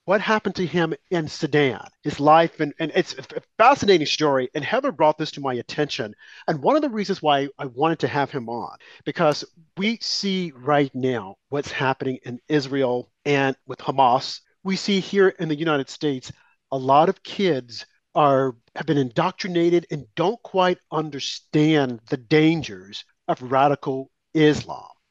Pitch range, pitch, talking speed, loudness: 135-170 Hz, 150 Hz, 165 wpm, -22 LUFS